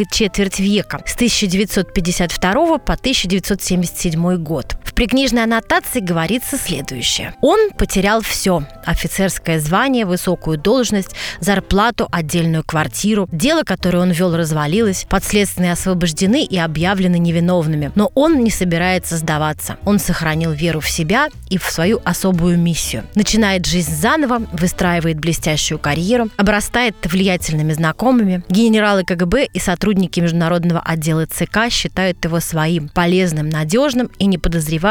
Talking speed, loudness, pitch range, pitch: 120 wpm, -16 LUFS, 170-210 Hz, 185 Hz